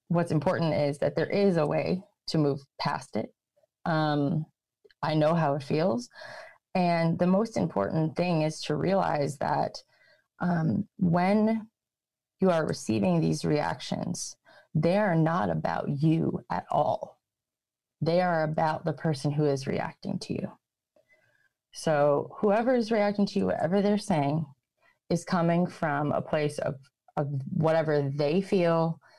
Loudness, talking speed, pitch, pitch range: -28 LUFS, 145 wpm, 165 Hz, 150-190 Hz